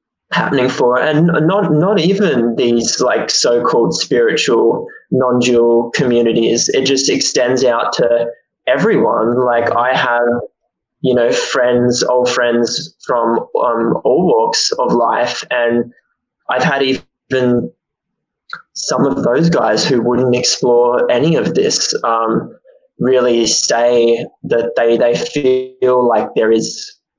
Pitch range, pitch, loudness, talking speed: 120-155 Hz, 125 Hz, -13 LUFS, 125 wpm